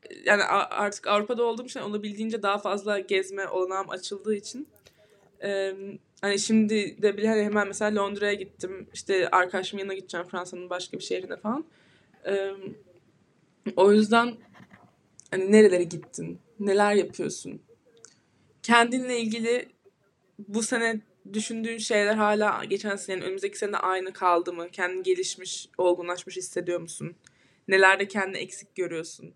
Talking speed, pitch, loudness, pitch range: 130 wpm, 200 Hz, -26 LUFS, 185-215 Hz